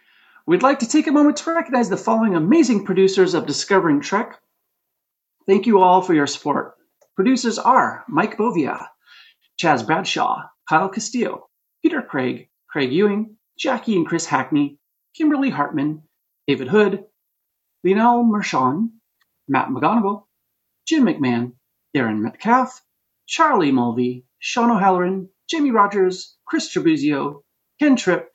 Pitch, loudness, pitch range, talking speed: 210 Hz, -19 LUFS, 180-260 Hz, 125 wpm